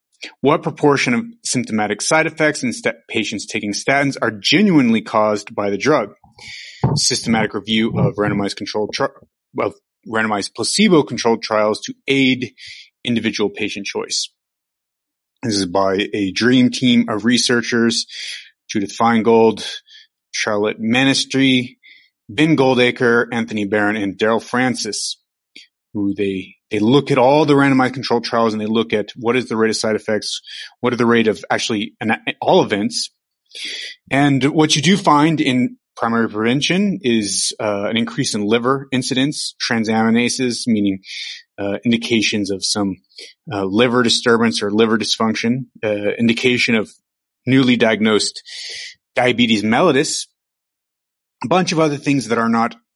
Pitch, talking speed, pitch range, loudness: 120 Hz, 140 wpm, 110-140 Hz, -17 LUFS